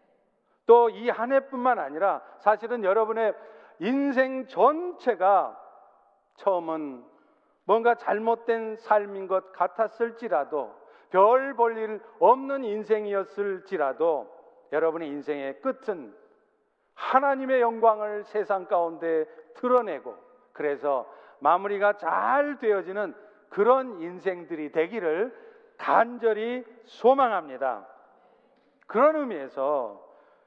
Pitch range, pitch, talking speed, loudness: 195-260 Hz, 225 Hz, 220 characters per minute, -26 LUFS